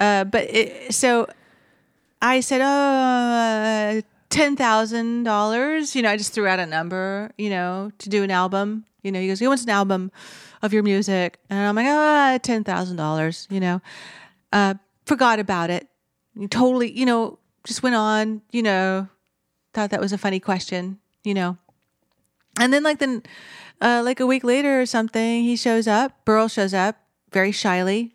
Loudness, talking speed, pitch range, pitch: -21 LUFS, 170 wpm, 195-240 Hz, 215 Hz